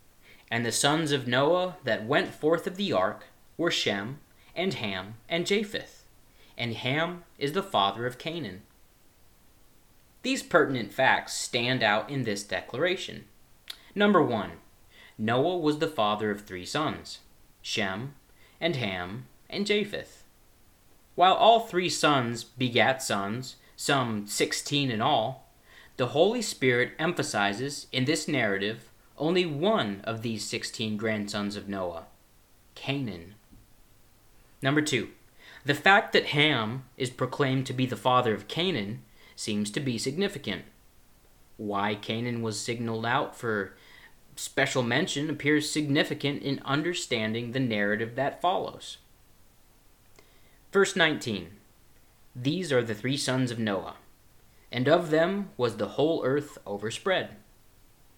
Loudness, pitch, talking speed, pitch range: -28 LUFS, 125 Hz, 125 wpm, 105-145 Hz